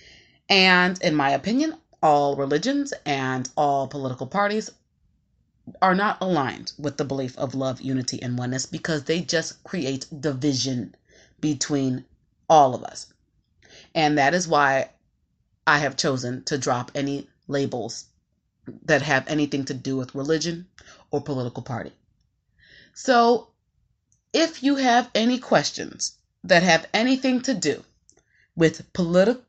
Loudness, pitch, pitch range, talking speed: -23 LUFS, 150 Hz, 135-185 Hz, 130 wpm